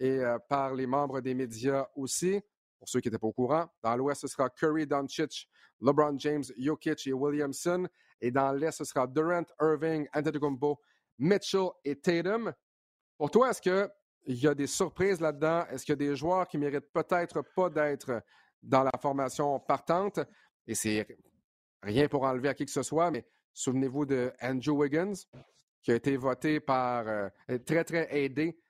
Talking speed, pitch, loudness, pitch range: 180 wpm, 145 Hz, -31 LUFS, 130-160 Hz